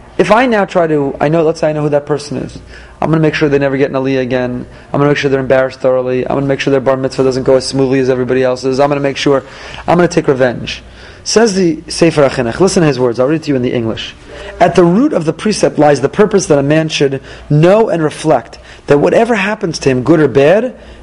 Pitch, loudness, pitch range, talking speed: 145 Hz, -12 LUFS, 135-165 Hz, 285 wpm